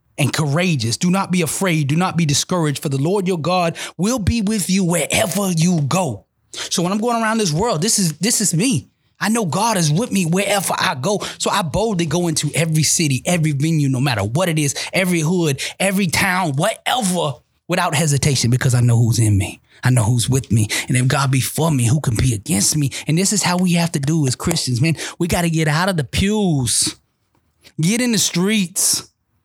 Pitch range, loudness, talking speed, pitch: 140-185 Hz, -17 LUFS, 220 wpm, 165 Hz